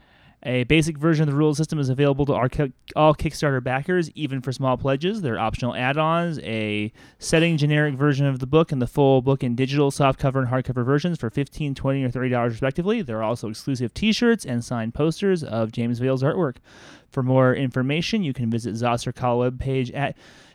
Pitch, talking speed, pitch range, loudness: 135 Hz, 190 wpm, 125-150 Hz, -22 LUFS